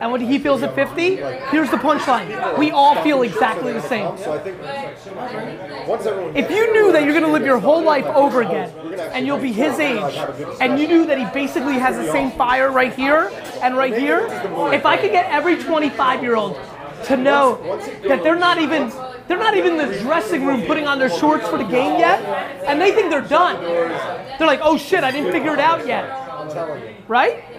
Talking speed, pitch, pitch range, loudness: 195 wpm, 285 Hz, 260-315 Hz, -18 LUFS